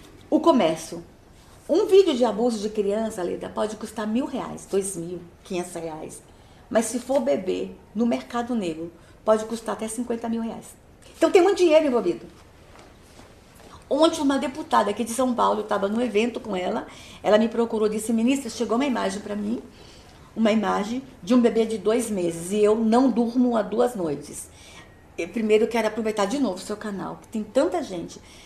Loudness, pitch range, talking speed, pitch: -24 LUFS, 205-245 Hz, 185 wpm, 225 Hz